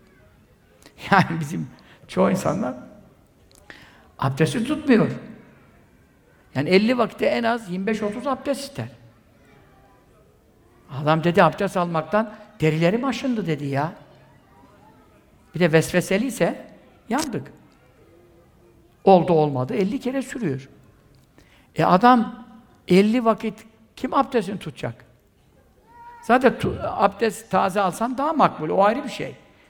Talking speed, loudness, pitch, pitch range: 100 wpm, -22 LUFS, 200 Hz, 160-235 Hz